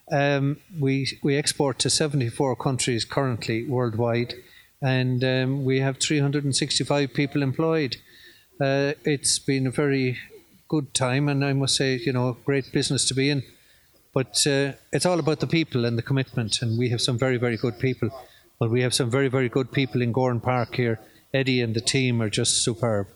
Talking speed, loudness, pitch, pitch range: 185 wpm, -24 LUFS, 135 Hz, 125-140 Hz